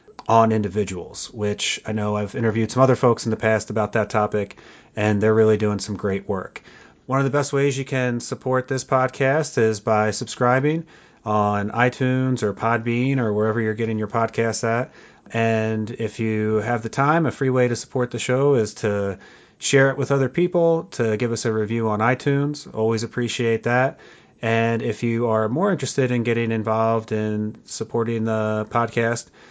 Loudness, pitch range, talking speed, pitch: -22 LUFS, 110-130 Hz, 185 wpm, 115 Hz